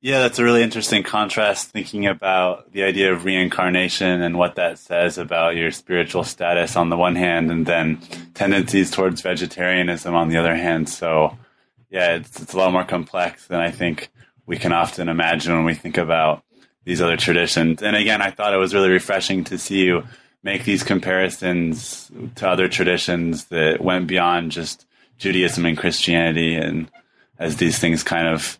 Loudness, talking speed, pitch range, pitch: -19 LUFS, 180 wpm, 85-95 Hz, 90 Hz